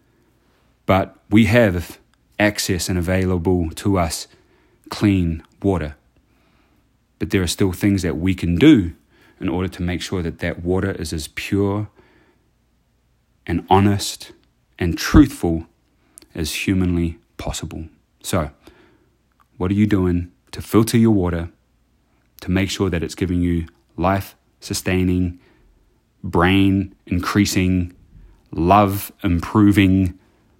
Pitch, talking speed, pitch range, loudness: 95 Hz, 115 wpm, 85-100 Hz, -19 LUFS